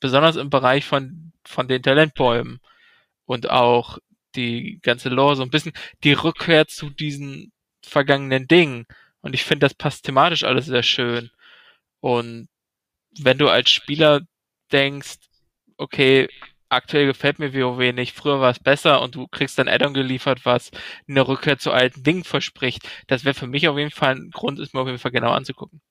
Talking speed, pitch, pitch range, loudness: 175 wpm, 135 Hz, 125-145 Hz, -19 LUFS